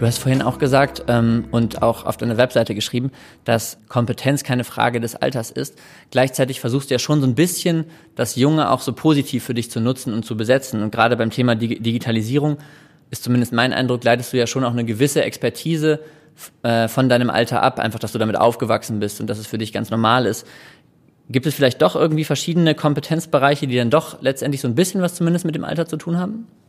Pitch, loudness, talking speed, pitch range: 130 Hz, -19 LUFS, 220 wpm, 115-150 Hz